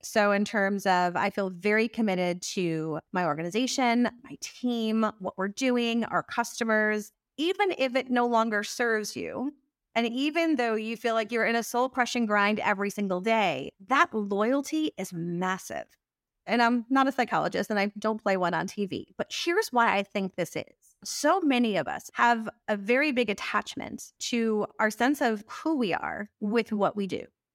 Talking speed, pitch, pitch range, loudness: 180 wpm, 225 Hz, 200-245 Hz, -27 LUFS